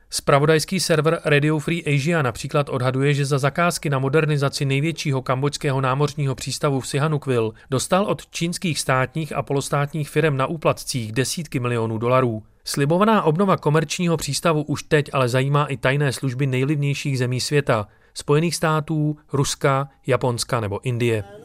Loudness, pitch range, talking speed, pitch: -21 LUFS, 130-155 Hz, 140 wpm, 145 Hz